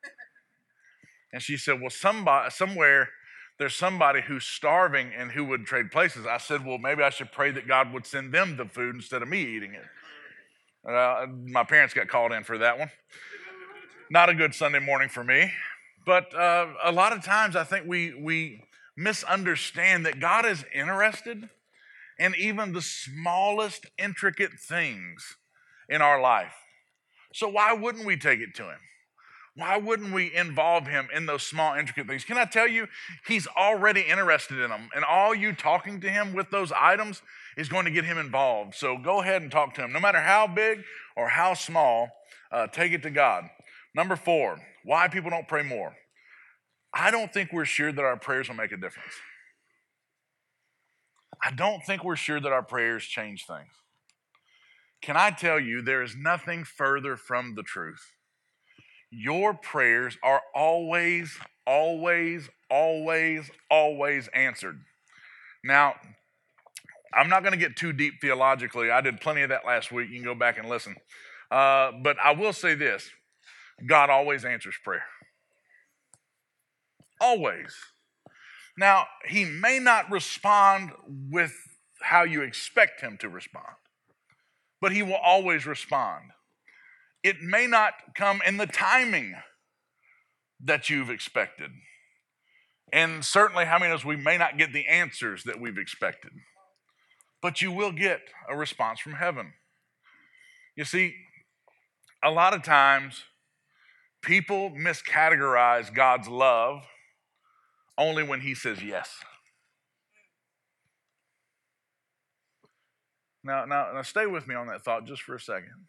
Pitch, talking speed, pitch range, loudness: 170 Hz, 155 wpm, 135-200 Hz, -25 LUFS